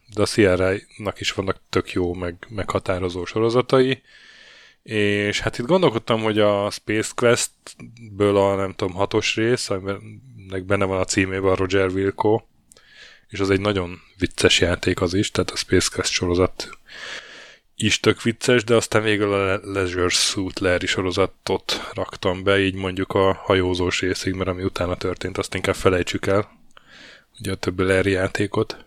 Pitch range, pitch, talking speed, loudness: 95-110 Hz, 100 Hz, 160 wpm, -21 LUFS